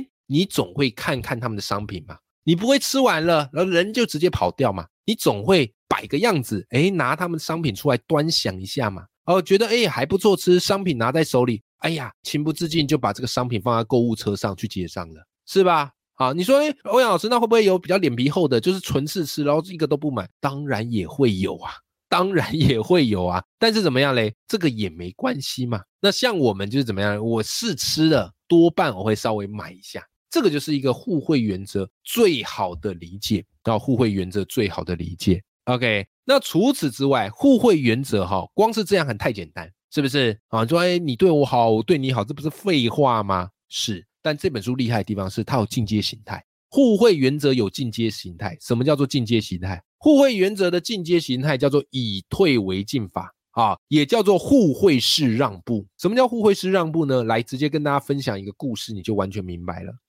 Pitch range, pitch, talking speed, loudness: 105-170 Hz, 130 Hz, 315 characters per minute, -21 LUFS